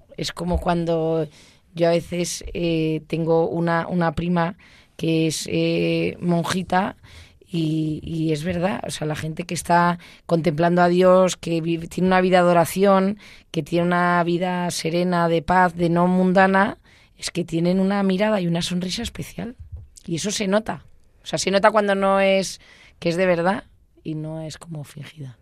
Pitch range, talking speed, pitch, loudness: 160-185 Hz, 175 wpm, 170 Hz, -21 LUFS